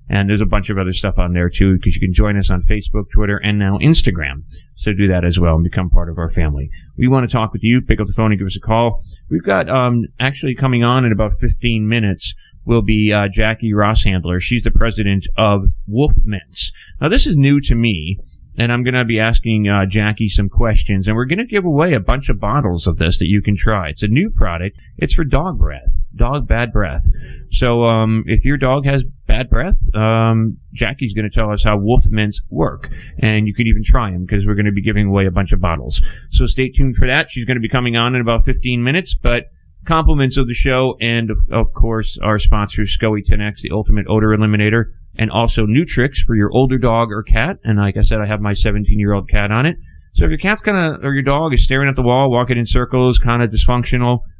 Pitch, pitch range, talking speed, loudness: 110 Hz, 100-125 Hz, 245 wpm, -16 LUFS